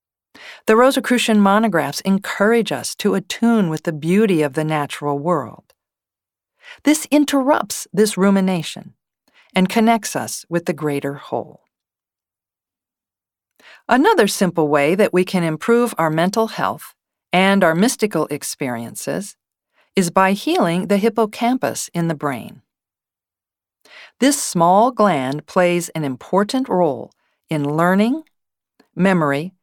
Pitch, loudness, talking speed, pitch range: 185 Hz, -18 LUFS, 115 wpm, 155-225 Hz